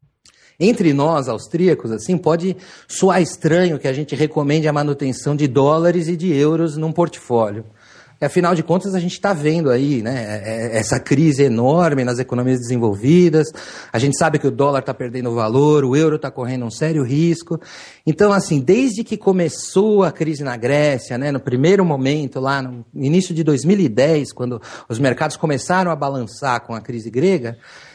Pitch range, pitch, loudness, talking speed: 130-170 Hz, 150 Hz, -17 LUFS, 170 wpm